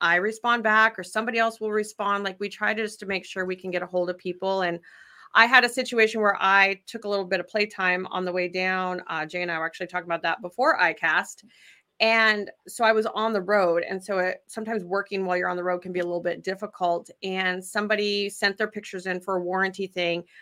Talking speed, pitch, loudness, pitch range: 250 wpm, 195 Hz, -24 LUFS, 180-215 Hz